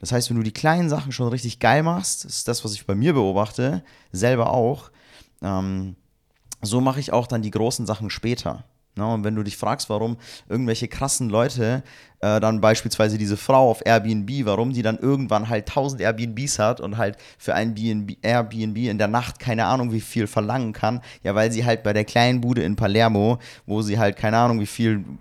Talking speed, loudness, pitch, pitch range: 205 wpm, -22 LUFS, 115 Hz, 105-125 Hz